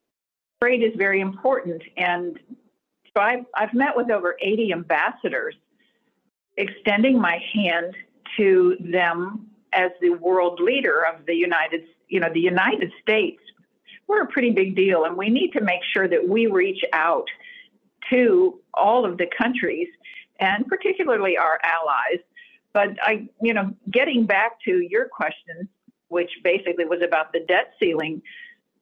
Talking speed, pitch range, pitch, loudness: 145 wpm, 180-265 Hz, 210 Hz, -21 LUFS